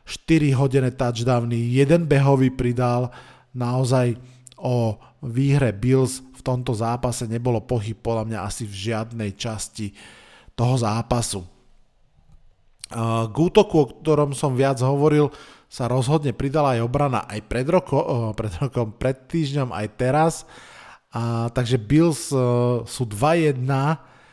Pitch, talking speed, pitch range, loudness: 125 Hz, 120 wpm, 115-140 Hz, -22 LUFS